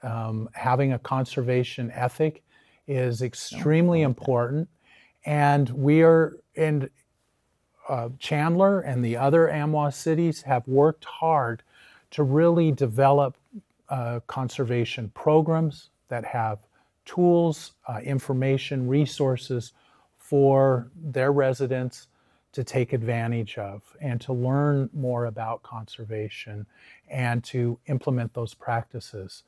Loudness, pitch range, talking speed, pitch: -25 LUFS, 120-150 Hz, 105 wpm, 135 Hz